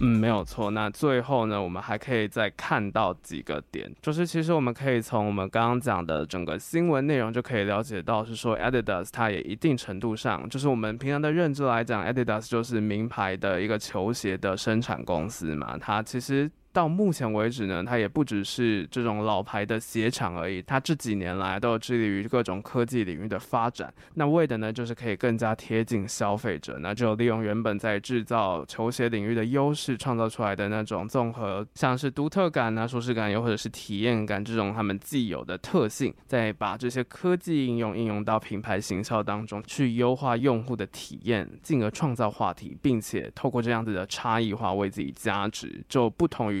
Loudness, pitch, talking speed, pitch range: -28 LUFS, 115 Hz, 325 characters per minute, 105-125 Hz